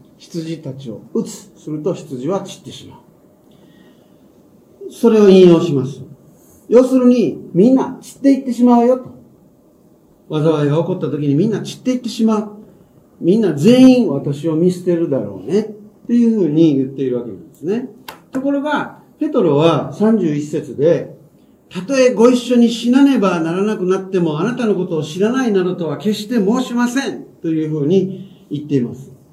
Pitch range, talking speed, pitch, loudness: 160-240 Hz, 330 characters per minute, 190 Hz, -15 LUFS